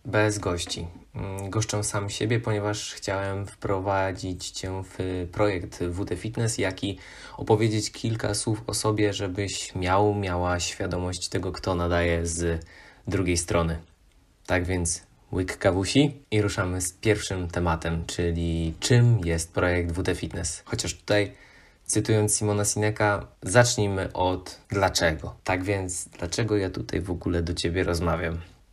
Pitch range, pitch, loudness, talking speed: 85-105 Hz, 95 Hz, -26 LUFS, 130 wpm